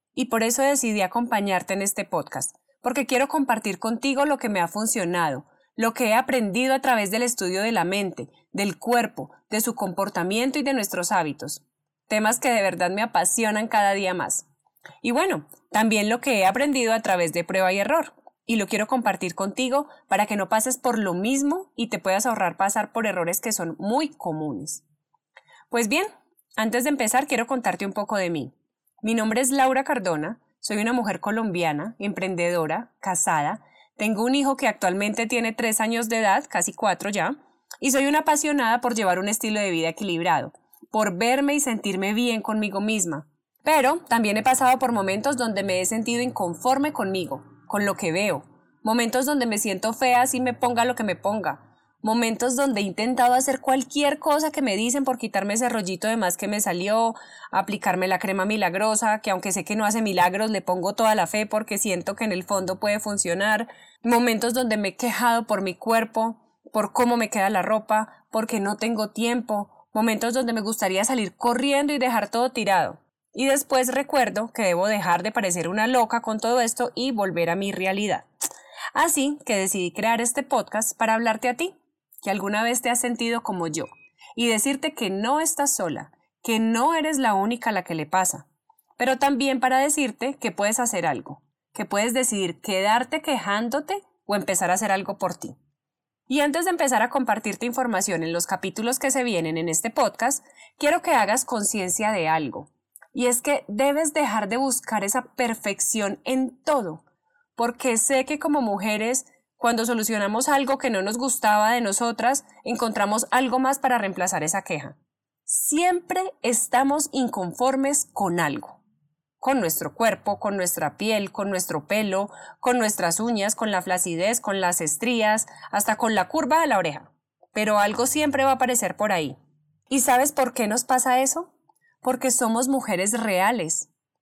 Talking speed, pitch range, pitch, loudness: 185 wpm, 195-255 Hz, 225 Hz, -23 LUFS